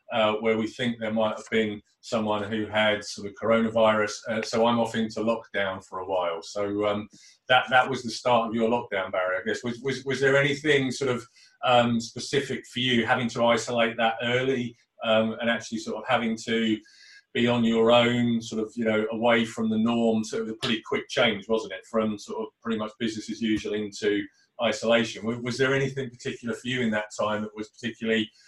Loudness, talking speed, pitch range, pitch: -26 LUFS, 215 wpm, 110-120 Hz, 115 Hz